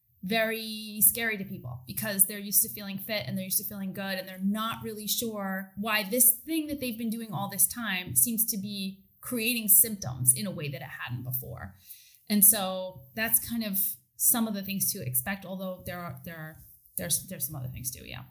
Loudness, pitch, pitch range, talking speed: -26 LUFS, 195 Hz, 170-220 Hz, 215 wpm